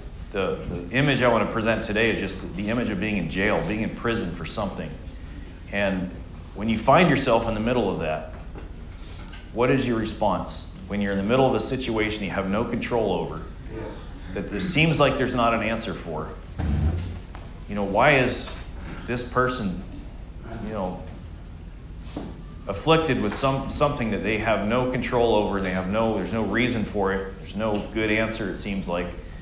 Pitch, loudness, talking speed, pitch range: 100 Hz, -24 LUFS, 185 wpm, 90-115 Hz